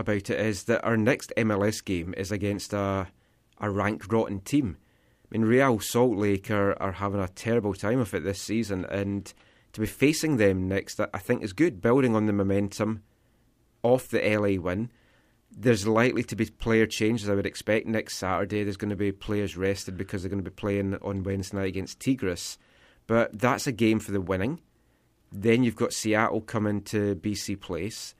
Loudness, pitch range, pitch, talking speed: -27 LUFS, 100-115 Hz, 105 Hz, 195 wpm